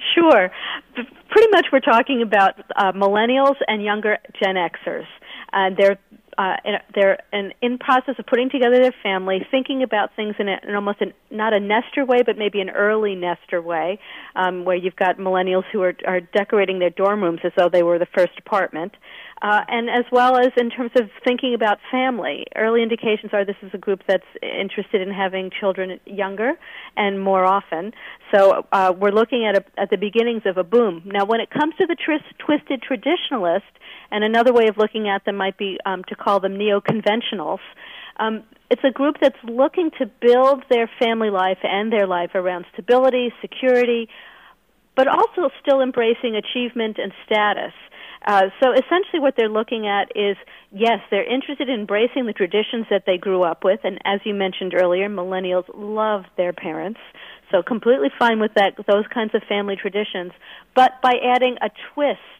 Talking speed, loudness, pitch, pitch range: 185 wpm, -19 LUFS, 215 Hz, 195-250 Hz